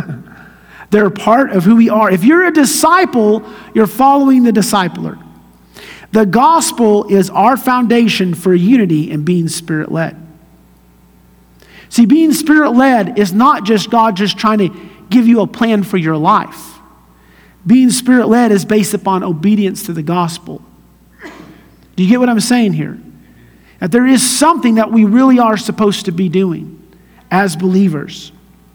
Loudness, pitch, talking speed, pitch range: -11 LUFS, 205 Hz, 155 wpm, 175-235 Hz